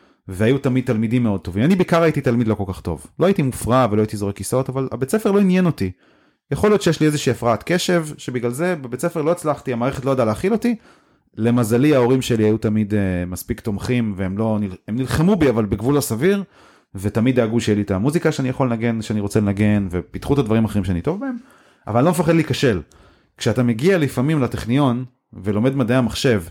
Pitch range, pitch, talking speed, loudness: 110-150 Hz, 125 Hz, 200 wpm, -19 LUFS